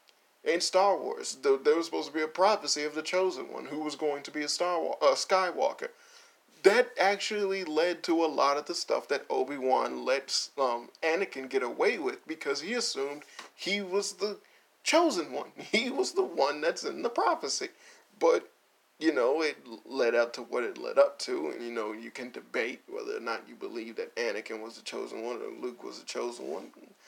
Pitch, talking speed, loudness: 290 Hz, 200 wpm, -30 LUFS